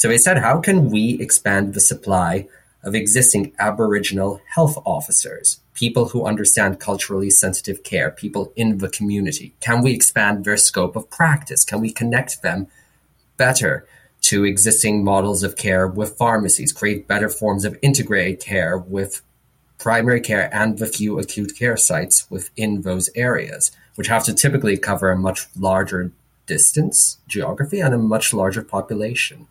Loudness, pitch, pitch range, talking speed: -17 LUFS, 105 Hz, 100-120 Hz, 155 wpm